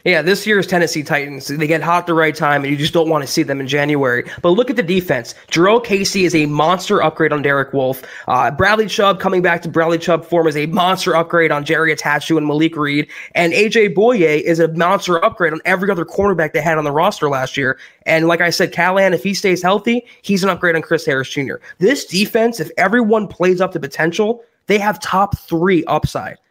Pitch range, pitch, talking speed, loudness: 155-195 Hz, 170 Hz, 230 wpm, -15 LUFS